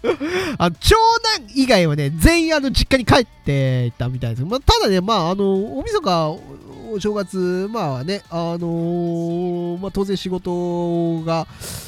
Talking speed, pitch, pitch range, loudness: 275 characters per minute, 180 Hz, 165-230 Hz, -19 LUFS